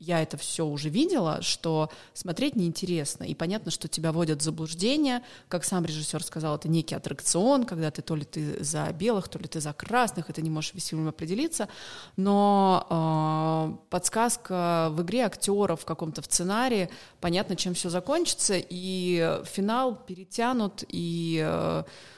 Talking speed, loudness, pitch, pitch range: 155 wpm, -28 LUFS, 175 Hz, 160-200 Hz